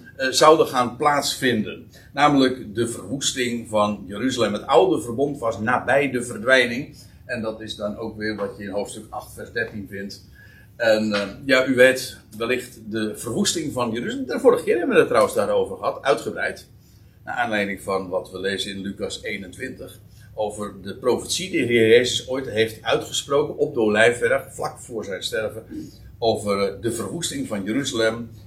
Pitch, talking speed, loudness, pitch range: 115 Hz, 165 wpm, -22 LUFS, 105-130 Hz